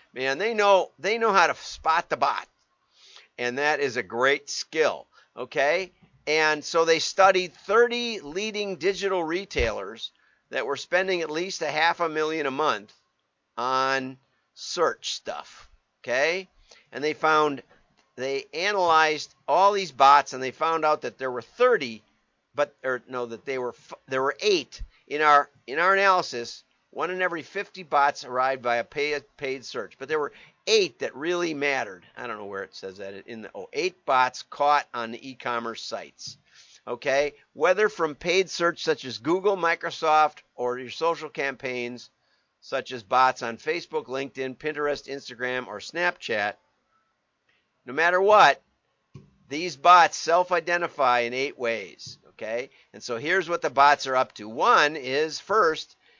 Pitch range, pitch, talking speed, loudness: 130-175 Hz, 150 Hz, 160 wpm, -24 LUFS